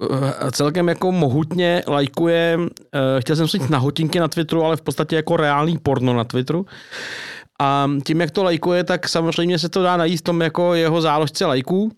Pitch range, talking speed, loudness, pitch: 145-175 Hz, 185 wpm, -19 LUFS, 165 Hz